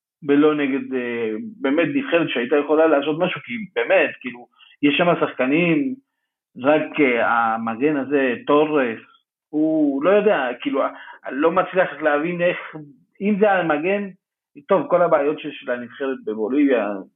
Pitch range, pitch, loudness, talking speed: 140-195 Hz, 155 Hz, -20 LUFS, 120 wpm